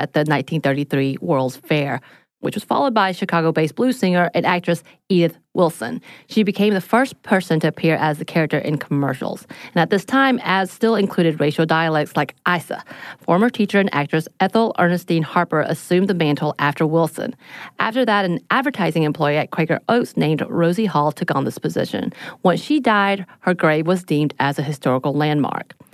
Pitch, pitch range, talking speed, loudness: 165 Hz, 150-190 Hz, 180 wpm, -19 LUFS